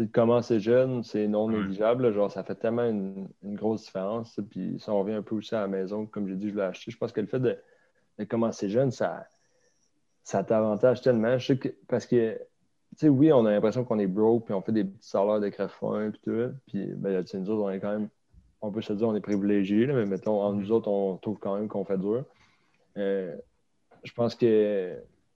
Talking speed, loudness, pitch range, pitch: 235 wpm, -28 LUFS, 100-115 Hz, 105 Hz